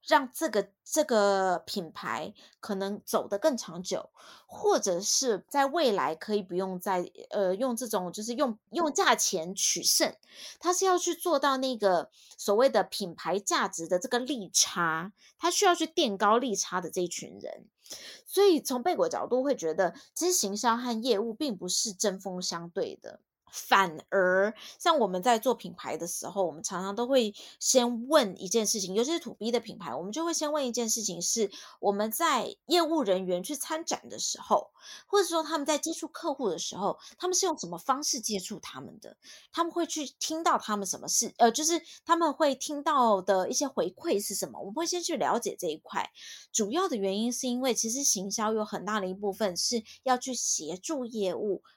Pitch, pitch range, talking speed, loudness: 230 Hz, 195-305 Hz, 280 characters per minute, -29 LUFS